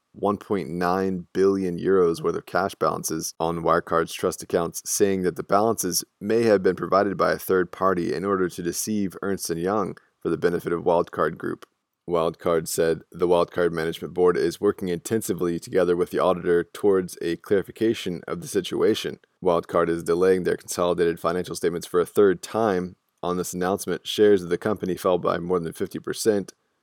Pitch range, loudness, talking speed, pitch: 85-95 Hz, -24 LUFS, 170 wpm, 90 Hz